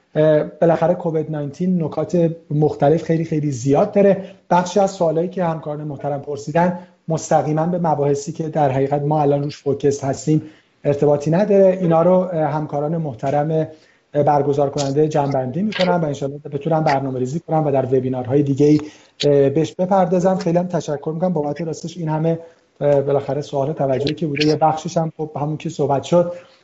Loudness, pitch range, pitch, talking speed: -19 LUFS, 145-165 Hz, 155 Hz, 160 wpm